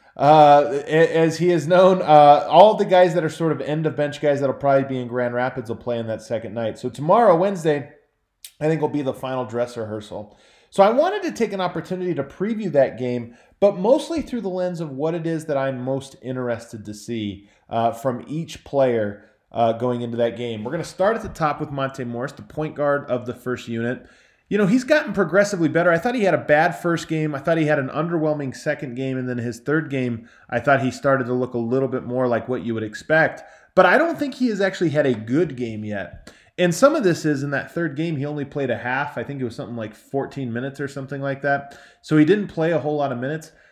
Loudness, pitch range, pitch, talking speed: -21 LUFS, 125-165 Hz, 140 Hz, 250 wpm